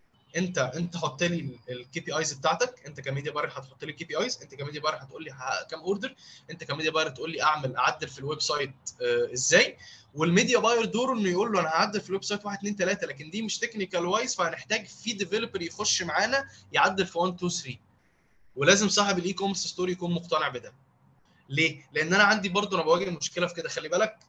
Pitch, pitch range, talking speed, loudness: 175 Hz, 155-205 Hz, 205 wpm, -27 LUFS